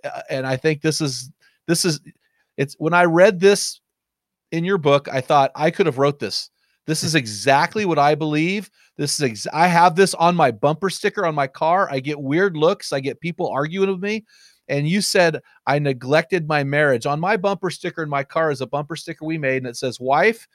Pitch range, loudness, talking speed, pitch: 140-180 Hz, -20 LUFS, 220 wpm, 155 Hz